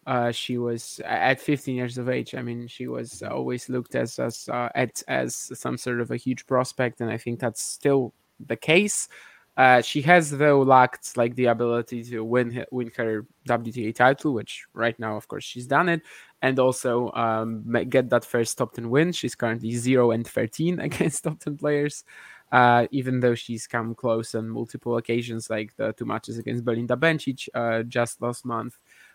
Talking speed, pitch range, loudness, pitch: 190 wpm, 115-130 Hz, -24 LUFS, 120 Hz